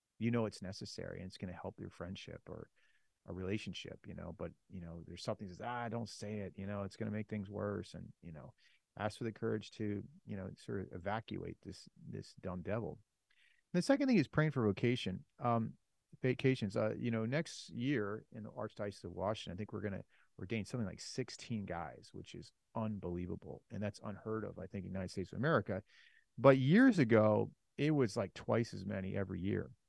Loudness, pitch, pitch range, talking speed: -38 LUFS, 105 Hz, 95-120 Hz, 215 wpm